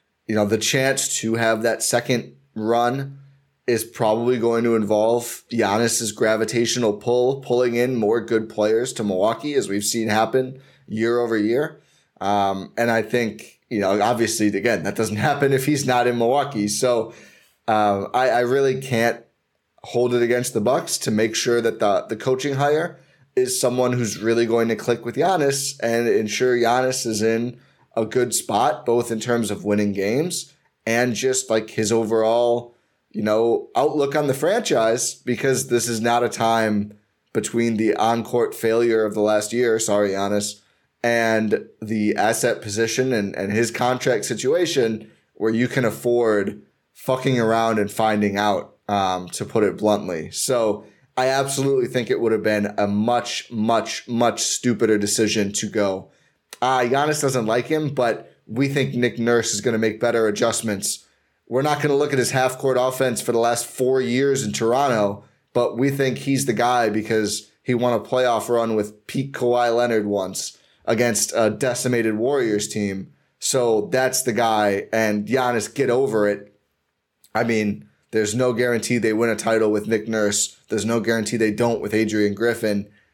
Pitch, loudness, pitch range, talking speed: 115 Hz, -21 LUFS, 110-125 Hz, 175 wpm